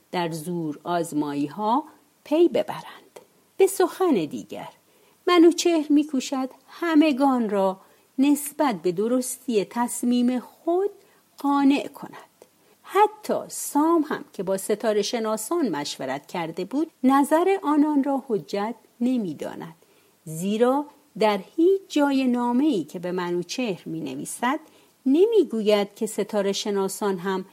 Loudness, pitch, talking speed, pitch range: -24 LUFS, 250 Hz, 110 wpm, 200-300 Hz